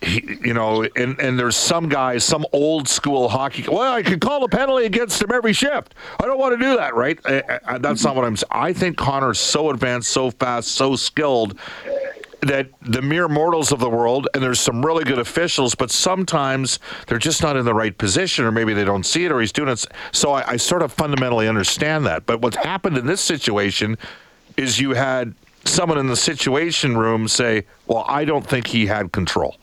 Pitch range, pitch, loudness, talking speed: 120-165 Hz, 135 Hz, -19 LUFS, 215 wpm